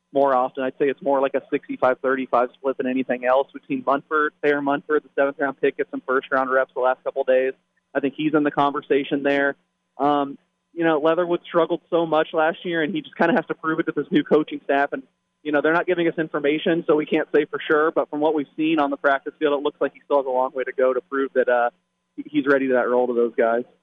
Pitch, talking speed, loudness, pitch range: 145 Hz, 270 wpm, -22 LUFS, 130-160 Hz